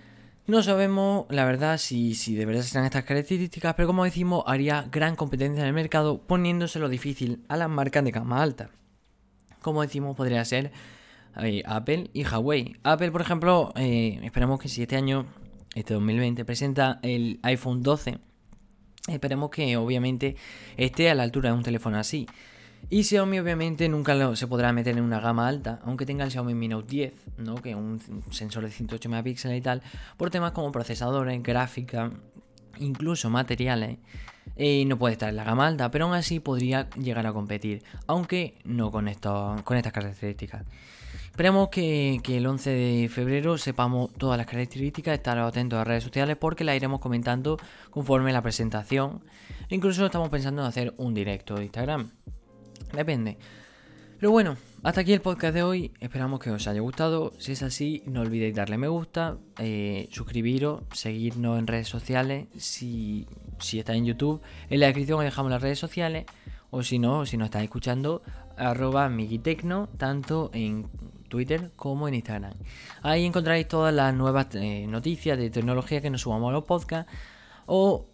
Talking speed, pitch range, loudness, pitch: 170 wpm, 115-150 Hz, -27 LUFS, 125 Hz